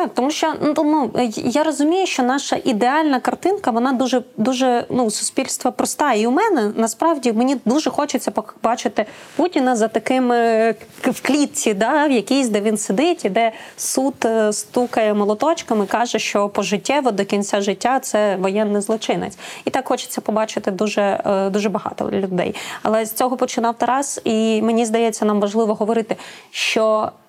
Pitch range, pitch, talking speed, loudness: 220-265 Hz, 235 Hz, 155 wpm, -19 LUFS